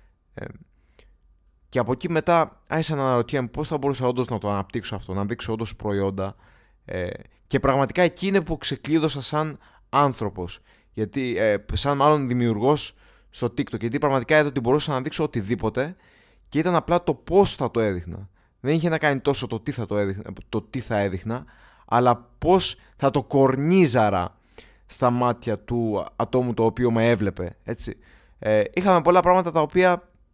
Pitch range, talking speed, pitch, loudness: 110-150 Hz, 170 wpm, 125 Hz, -23 LUFS